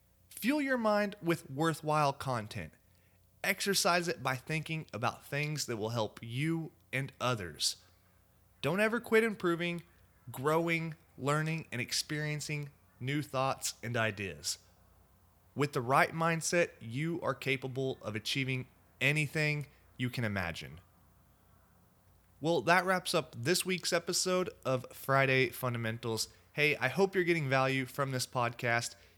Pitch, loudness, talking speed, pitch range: 130 Hz, -33 LUFS, 130 wpm, 110-160 Hz